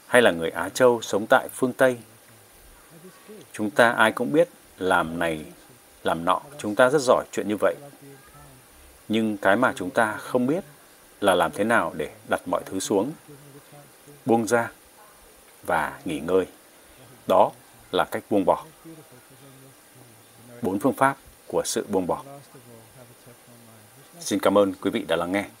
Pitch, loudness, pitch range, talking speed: 125 Hz, -24 LUFS, 105-140 Hz, 155 wpm